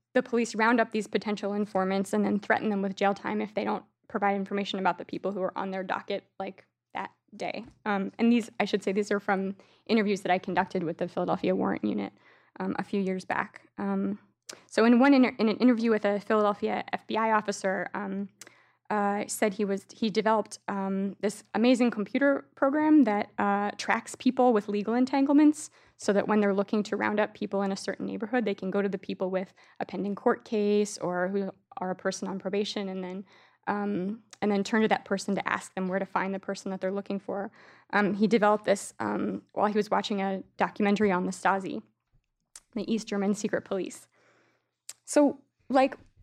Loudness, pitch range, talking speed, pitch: -28 LUFS, 195-220 Hz, 210 wpm, 205 Hz